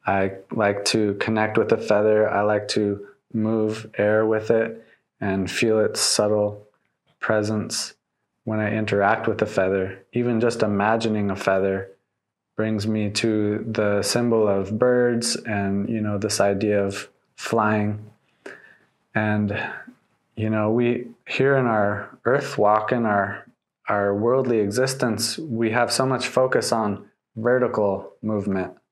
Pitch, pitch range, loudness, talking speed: 110 Hz, 100-115 Hz, -22 LUFS, 135 wpm